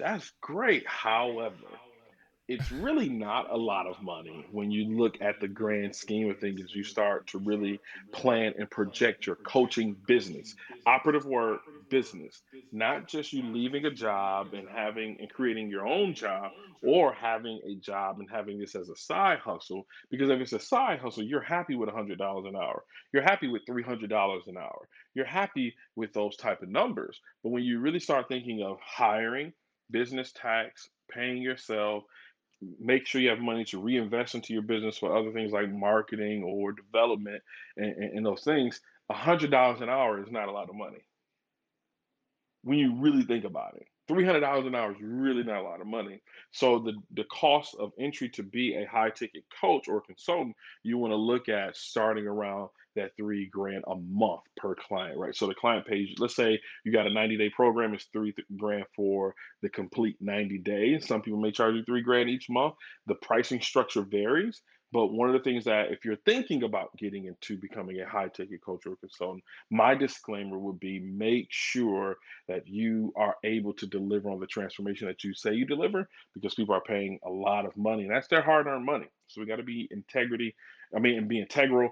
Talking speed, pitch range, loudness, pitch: 195 wpm, 100-125 Hz, -30 LUFS, 110 Hz